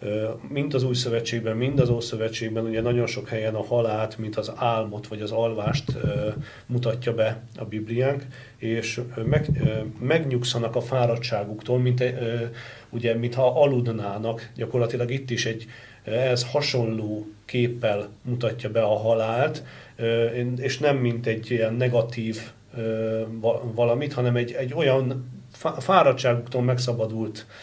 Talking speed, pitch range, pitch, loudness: 125 wpm, 110-125 Hz, 120 Hz, -25 LUFS